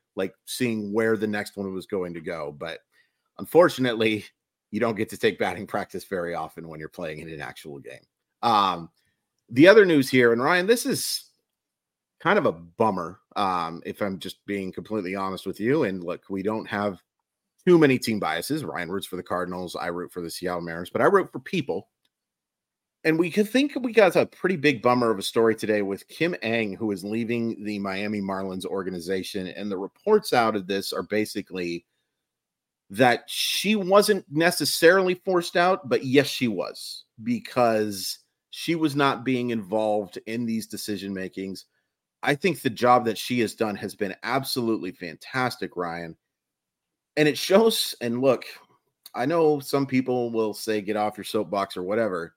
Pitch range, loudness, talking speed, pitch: 100-140 Hz, -24 LUFS, 180 wpm, 110 Hz